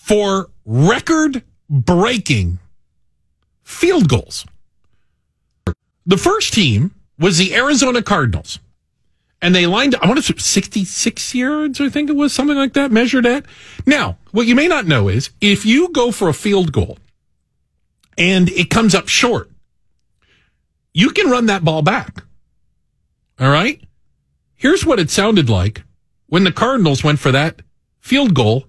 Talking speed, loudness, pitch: 150 wpm, -14 LUFS, 195 Hz